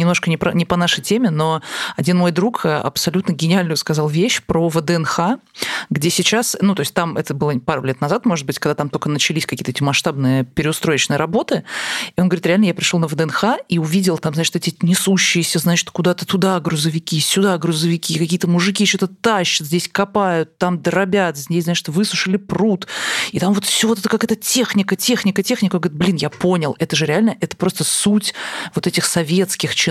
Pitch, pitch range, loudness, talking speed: 175 Hz, 160-195 Hz, -17 LUFS, 195 wpm